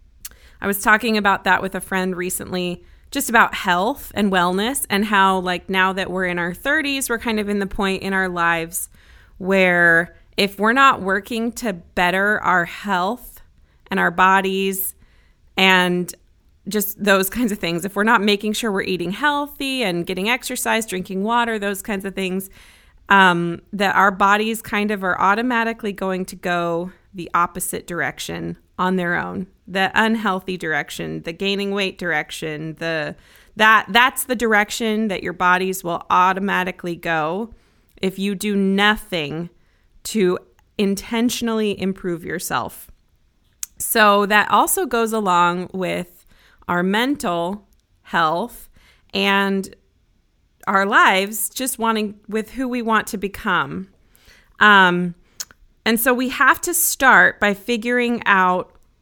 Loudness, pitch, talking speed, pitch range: -19 LUFS, 195 Hz, 140 wpm, 180-215 Hz